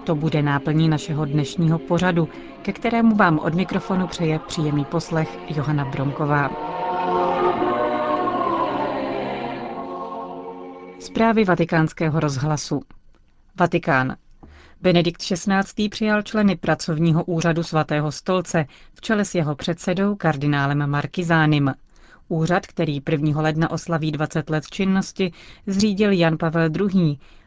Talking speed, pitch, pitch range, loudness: 105 wpm, 160 Hz, 145-180 Hz, -21 LUFS